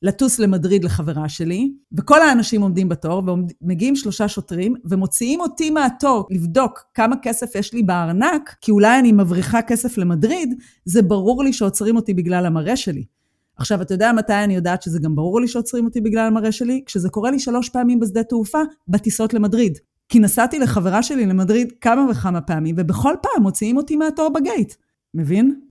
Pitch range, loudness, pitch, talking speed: 190-250 Hz, -18 LUFS, 220 Hz, 170 wpm